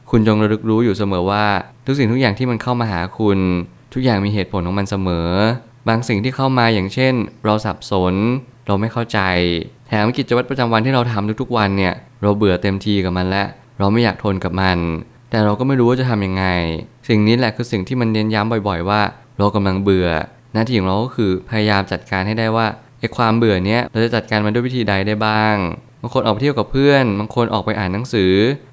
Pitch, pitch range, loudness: 110 Hz, 100-120 Hz, -17 LUFS